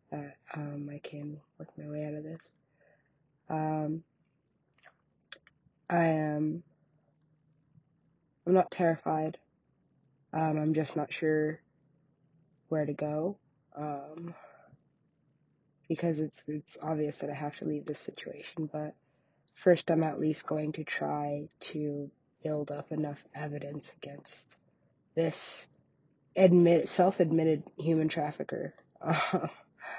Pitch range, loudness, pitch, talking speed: 150-160 Hz, -32 LUFS, 155 Hz, 110 wpm